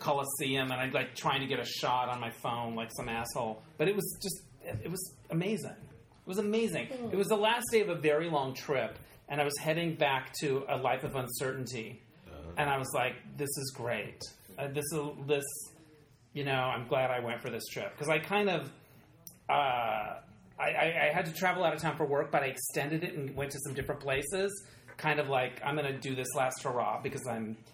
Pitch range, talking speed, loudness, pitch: 130-155 Hz, 225 wpm, -33 LUFS, 145 Hz